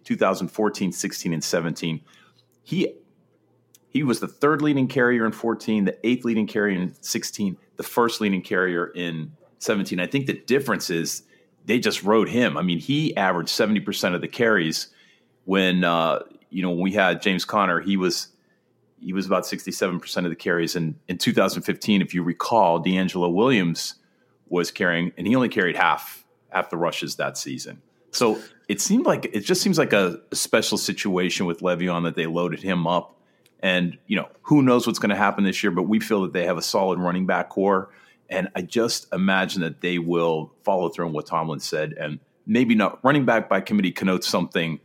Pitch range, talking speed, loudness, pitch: 90-110 Hz, 190 wpm, -23 LUFS, 95 Hz